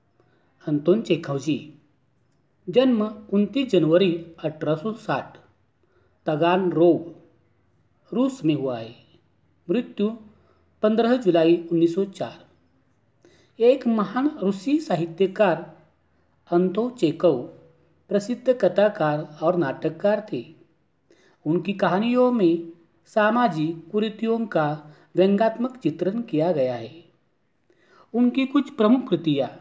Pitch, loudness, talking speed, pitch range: 175 Hz, -23 LUFS, 95 wpm, 160-215 Hz